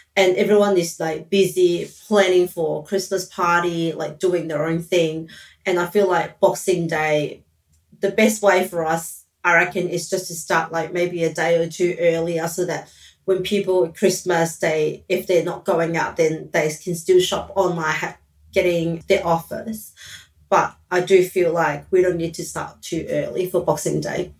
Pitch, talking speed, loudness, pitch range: 175 Hz, 180 wpm, -20 LUFS, 165-185 Hz